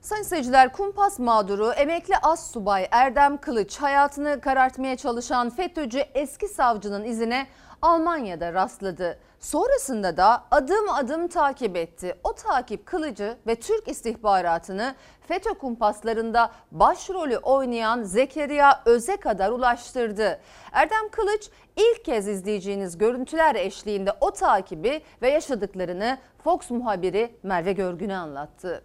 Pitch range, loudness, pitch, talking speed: 210-310 Hz, -24 LUFS, 255 Hz, 110 wpm